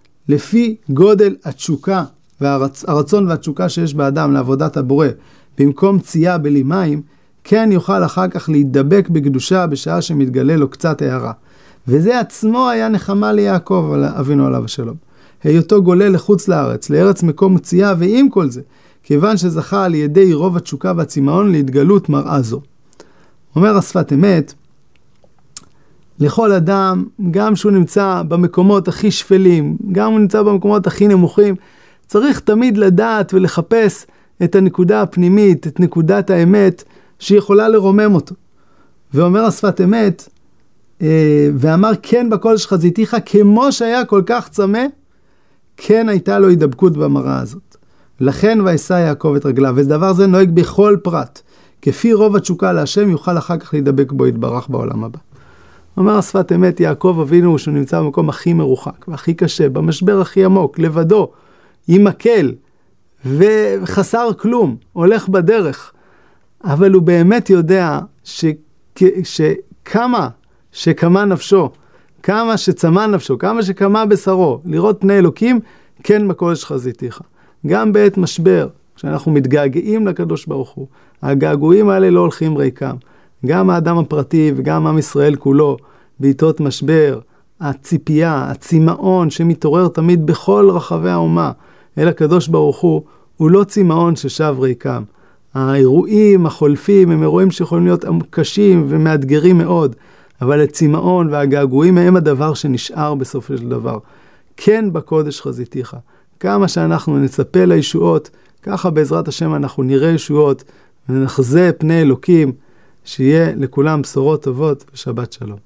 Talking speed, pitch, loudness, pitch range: 130 wpm, 170 Hz, -13 LUFS, 145-195 Hz